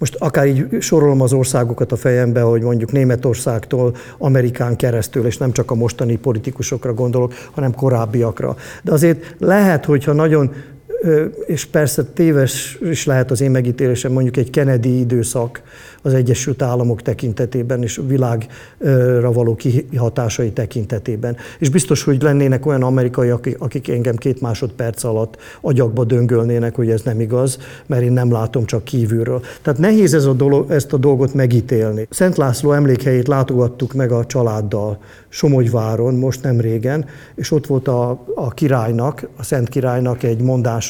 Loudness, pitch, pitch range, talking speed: -16 LUFS, 125 Hz, 120-140 Hz, 150 wpm